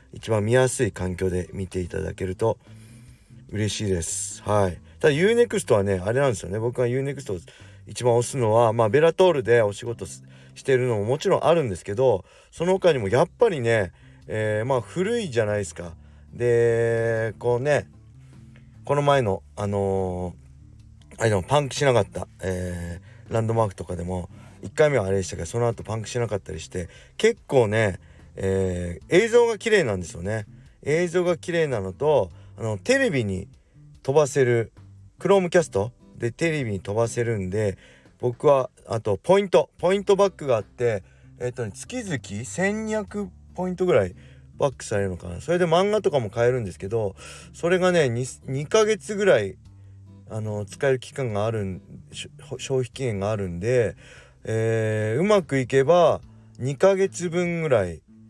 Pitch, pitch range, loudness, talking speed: 115 Hz, 100-140 Hz, -23 LUFS, 335 characters per minute